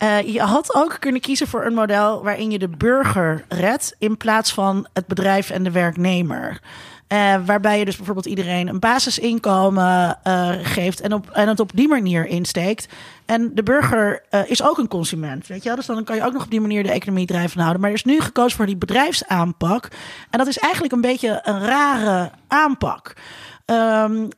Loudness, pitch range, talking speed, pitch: -19 LUFS, 185-235 Hz, 200 wpm, 210 Hz